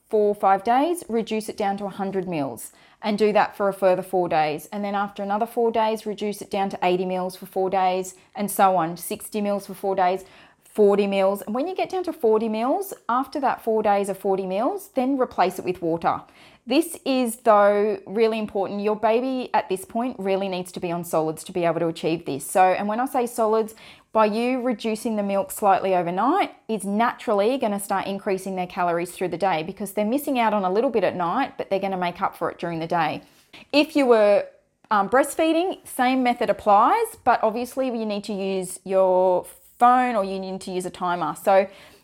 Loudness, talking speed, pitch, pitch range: -23 LUFS, 220 wpm, 205 Hz, 190-230 Hz